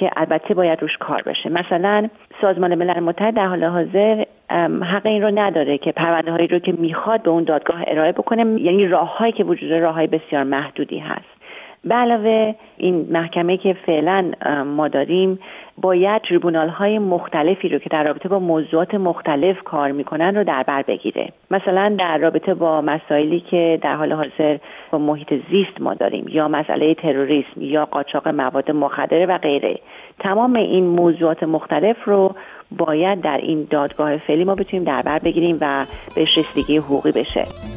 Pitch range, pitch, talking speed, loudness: 150-190 Hz, 165 Hz, 165 wpm, -18 LUFS